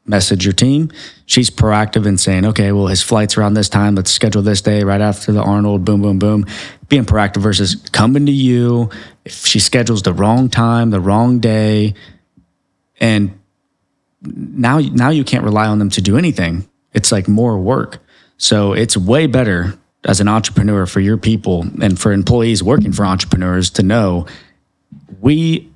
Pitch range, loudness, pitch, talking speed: 100-115 Hz, -13 LUFS, 105 Hz, 170 wpm